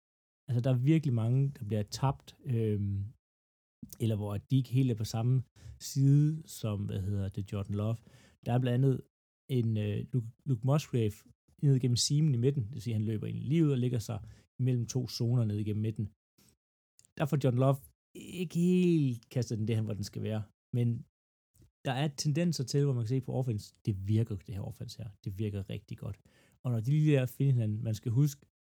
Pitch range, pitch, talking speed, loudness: 105-135 Hz, 120 Hz, 205 wpm, -32 LUFS